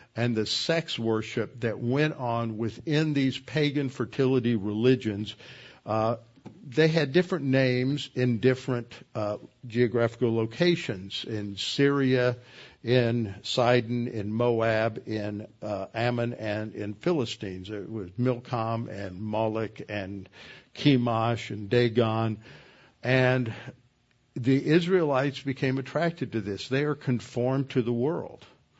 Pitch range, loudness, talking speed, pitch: 110-130 Hz, -27 LUFS, 115 wpm, 120 Hz